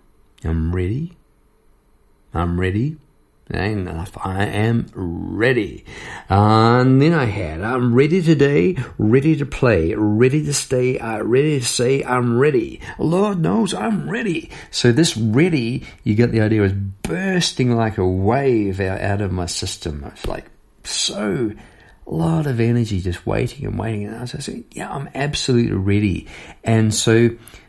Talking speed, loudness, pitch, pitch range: 150 wpm, -19 LUFS, 115 Hz, 100-140 Hz